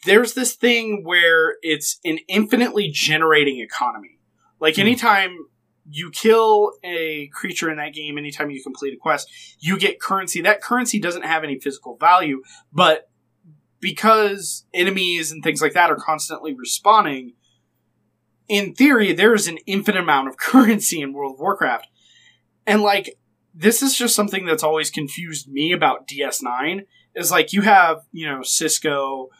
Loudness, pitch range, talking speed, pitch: -18 LUFS, 150-205 Hz, 150 wpm, 165 Hz